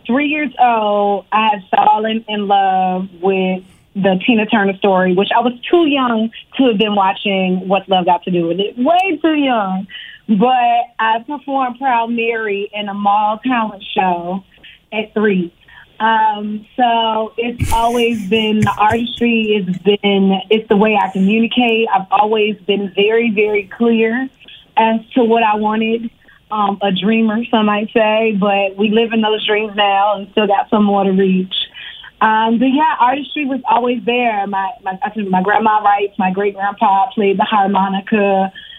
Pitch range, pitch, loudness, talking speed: 195-230 Hz, 215 Hz, -15 LUFS, 170 wpm